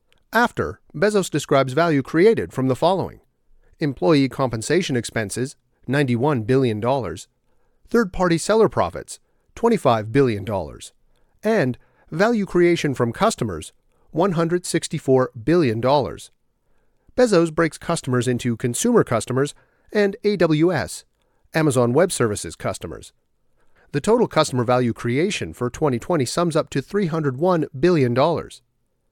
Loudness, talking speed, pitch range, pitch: -20 LUFS, 105 wpm, 125-175 Hz, 145 Hz